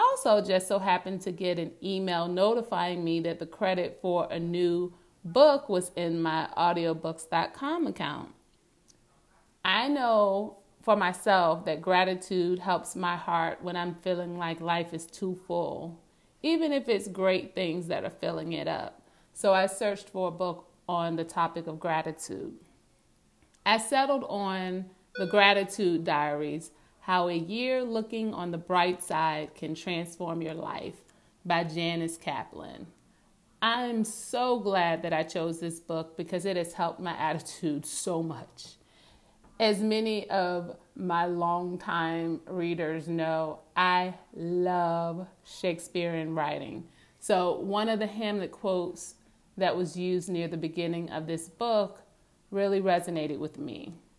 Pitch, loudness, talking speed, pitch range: 175 Hz, -29 LUFS, 140 wpm, 165-195 Hz